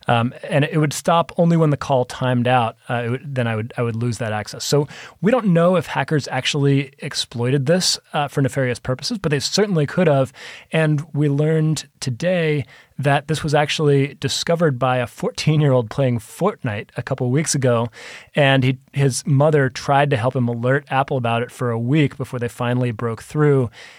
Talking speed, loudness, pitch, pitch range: 200 wpm, -19 LUFS, 140 Hz, 125-155 Hz